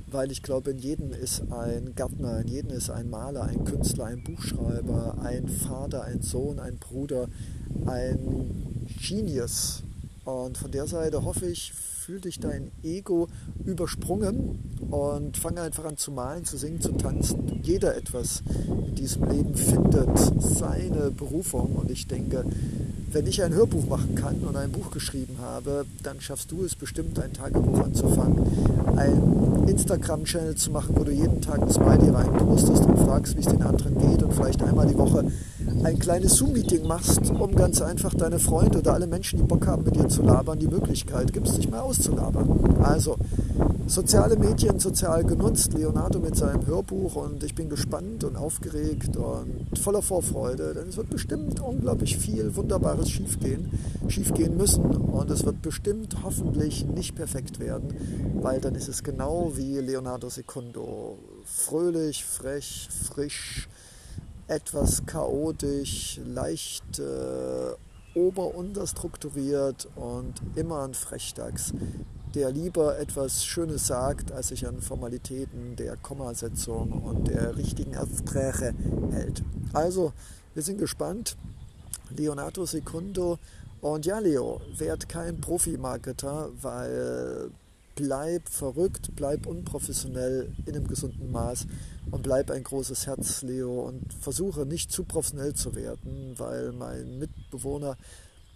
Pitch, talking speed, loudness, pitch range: 130 Hz, 140 wpm, -27 LUFS, 110-150 Hz